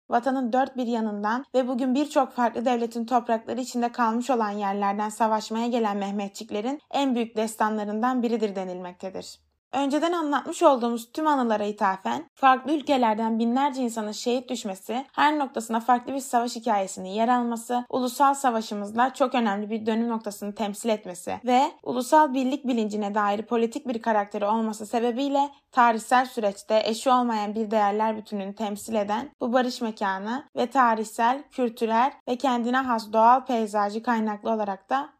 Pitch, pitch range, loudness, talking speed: 235 Hz, 215-255 Hz, -25 LUFS, 145 wpm